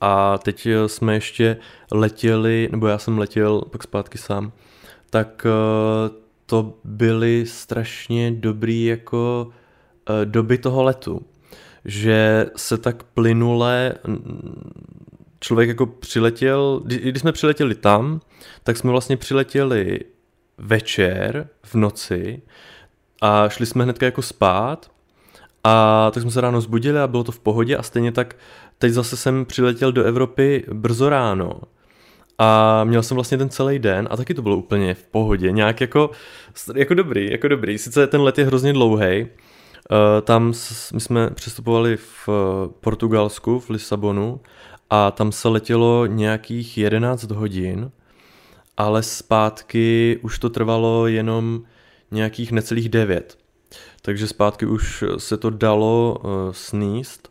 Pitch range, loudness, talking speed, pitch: 110-125 Hz, -19 LUFS, 130 wpm, 115 Hz